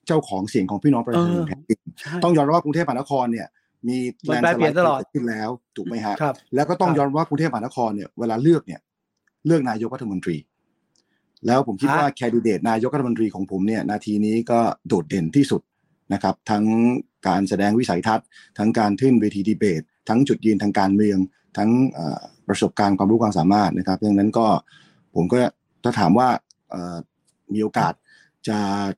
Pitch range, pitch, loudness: 100-135 Hz, 110 Hz, -21 LUFS